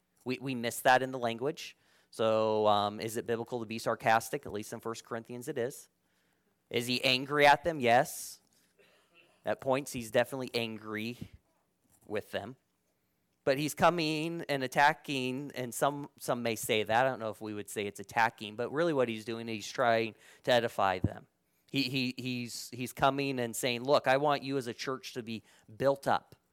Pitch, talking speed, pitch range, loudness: 120 Hz, 190 wpm, 110-135 Hz, -32 LUFS